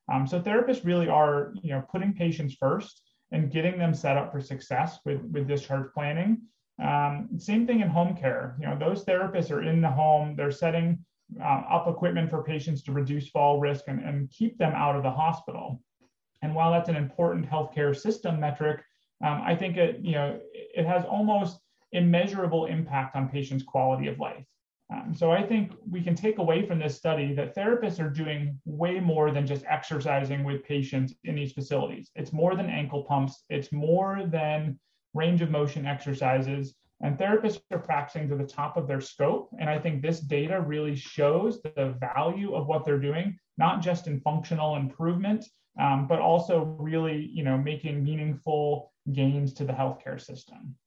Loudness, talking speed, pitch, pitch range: -28 LUFS, 185 wpm, 155 Hz, 145-170 Hz